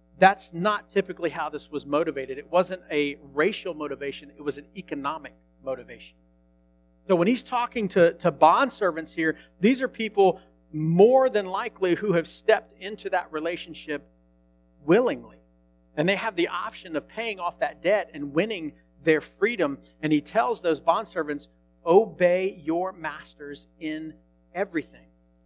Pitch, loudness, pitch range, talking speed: 160 Hz, -25 LUFS, 135-190 Hz, 150 wpm